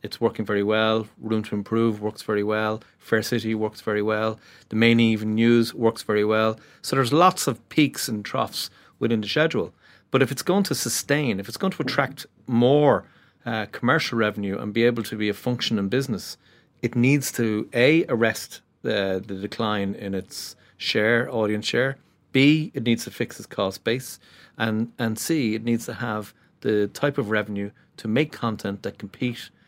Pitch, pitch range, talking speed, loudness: 115 Hz, 105-125 Hz, 190 wpm, -24 LUFS